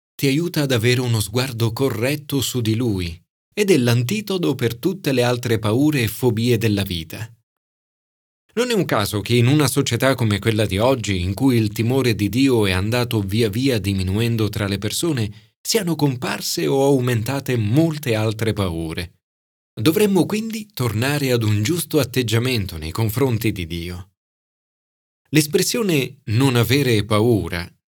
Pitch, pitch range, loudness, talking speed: 120 Hz, 105-140 Hz, -20 LUFS, 150 wpm